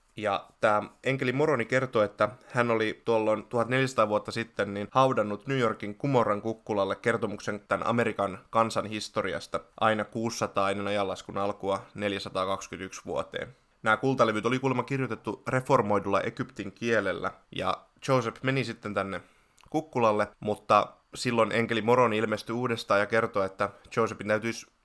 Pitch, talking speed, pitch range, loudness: 110 Hz, 135 wpm, 100-120 Hz, -28 LUFS